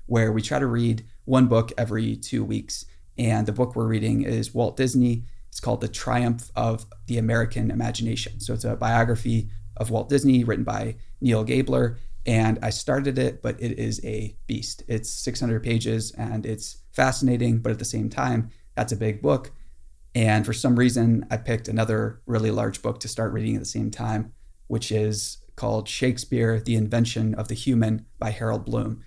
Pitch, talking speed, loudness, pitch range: 115 Hz, 185 wpm, -25 LUFS, 110-120 Hz